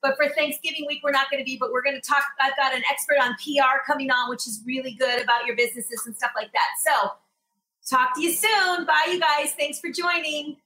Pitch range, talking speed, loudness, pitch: 250-305 Hz, 250 wpm, -23 LUFS, 275 Hz